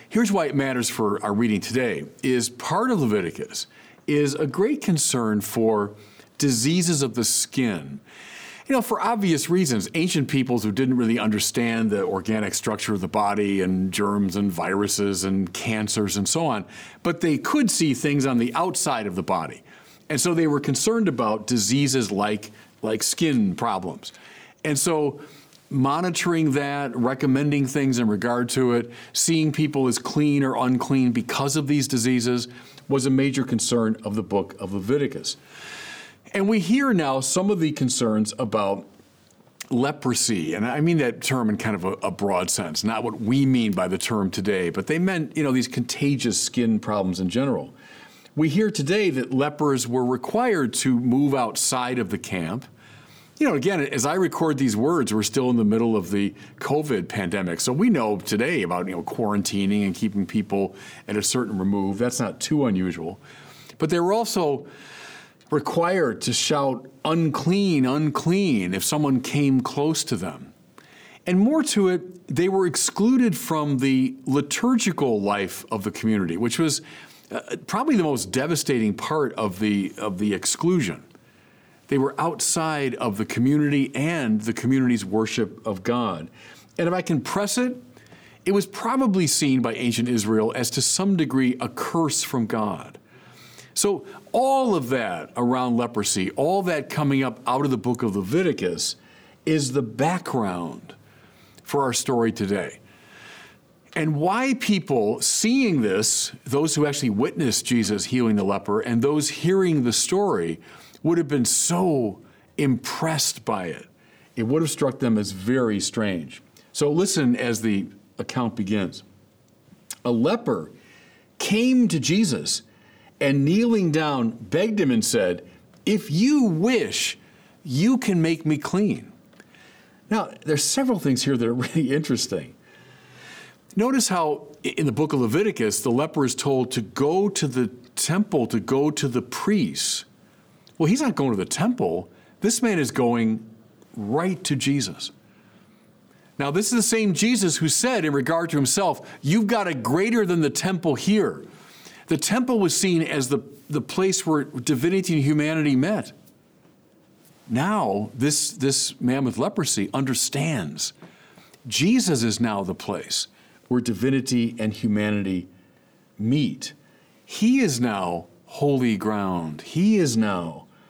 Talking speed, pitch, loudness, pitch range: 155 wpm, 135 Hz, -23 LUFS, 115-165 Hz